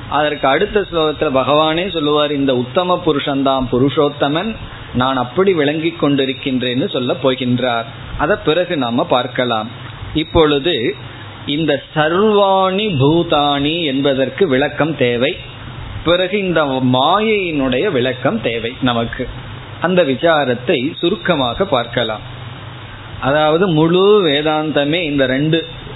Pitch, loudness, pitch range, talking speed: 140 Hz, -15 LUFS, 125-160 Hz, 95 wpm